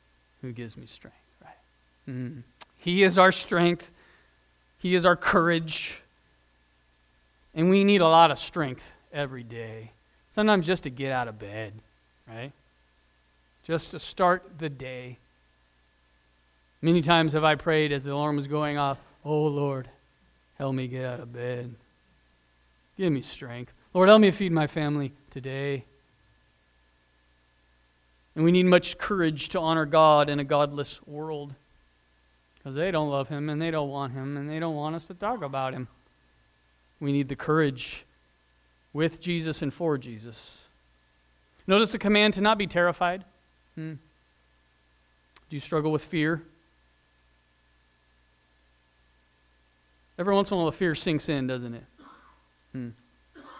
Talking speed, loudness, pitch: 145 wpm, -25 LUFS, 130 Hz